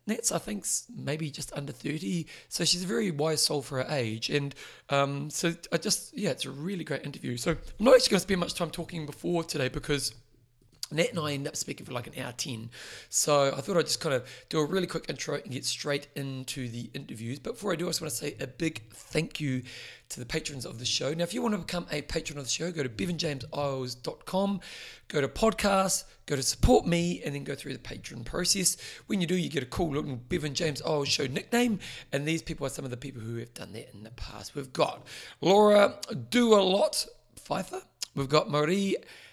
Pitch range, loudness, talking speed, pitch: 135-180 Hz, -29 LUFS, 230 wpm, 150 Hz